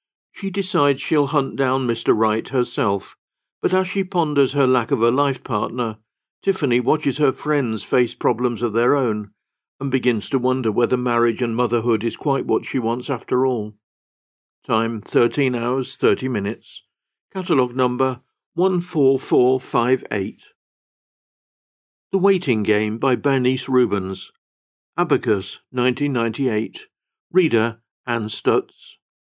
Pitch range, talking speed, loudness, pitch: 115-140 Hz, 125 wpm, -20 LUFS, 125 Hz